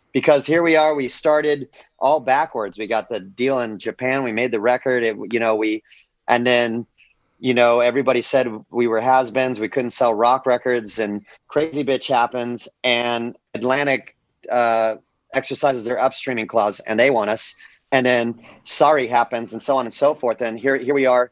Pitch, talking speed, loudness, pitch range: 125 Hz, 185 wpm, -19 LUFS, 115-130 Hz